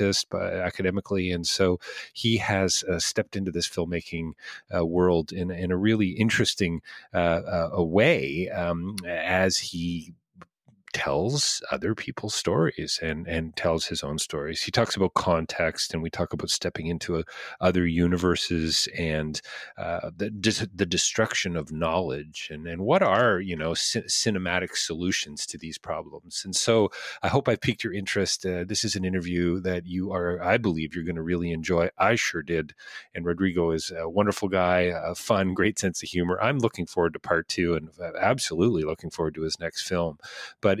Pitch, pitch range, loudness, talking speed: 90 Hz, 85-95 Hz, -26 LUFS, 175 wpm